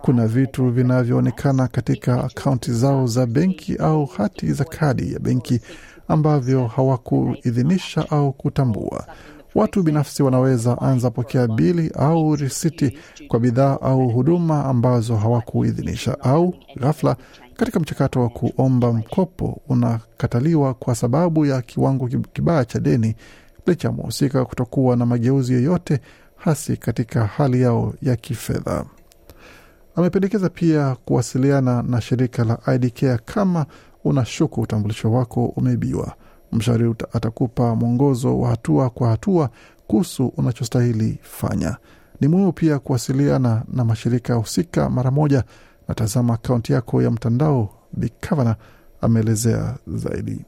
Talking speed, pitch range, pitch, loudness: 120 wpm, 120-145 Hz, 130 Hz, -20 LUFS